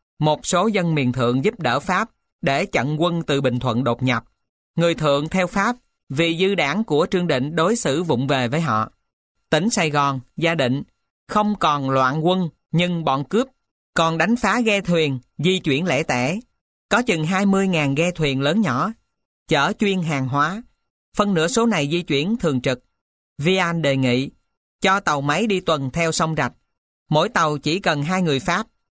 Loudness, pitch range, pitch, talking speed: -20 LUFS, 140-190 Hz, 160 Hz, 185 wpm